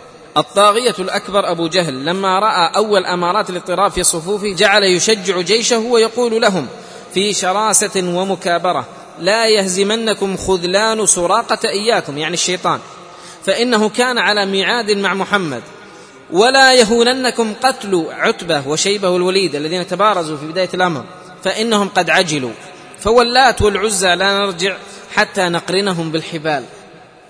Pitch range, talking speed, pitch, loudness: 180-215 Hz, 115 wpm, 195 Hz, -14 LUFS